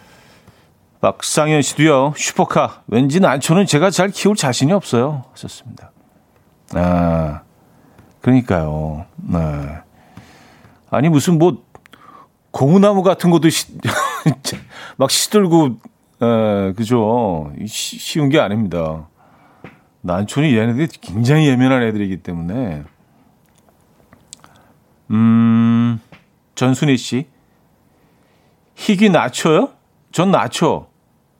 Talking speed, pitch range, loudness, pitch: 190 characters per minute, 95-155 Hz, -16 LUFS, 120 Hz